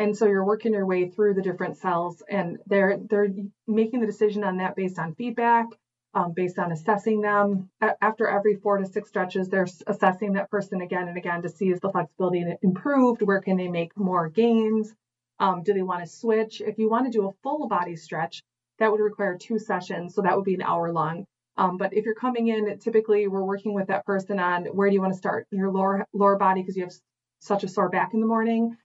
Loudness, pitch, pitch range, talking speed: -25 LUFS, 195 Hz, 185-215 Hz, 230 wpm